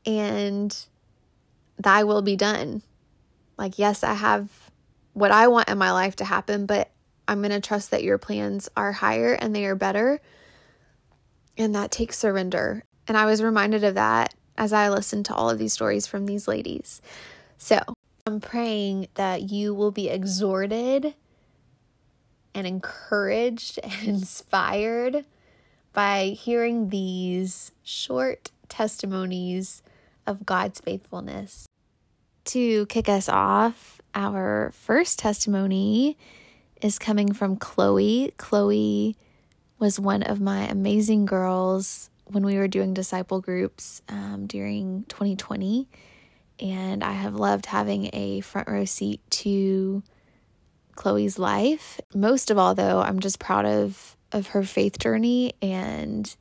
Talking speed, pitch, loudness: 130 wpm, 195 Hz, -24 LUFS